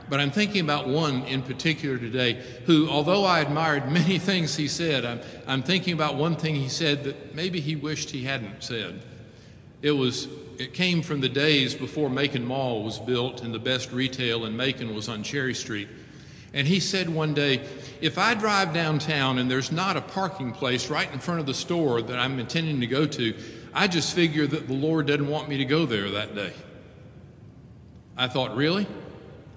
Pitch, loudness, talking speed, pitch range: 140 Hz, -25 LUFS, 195 wpm, 125-155 Hz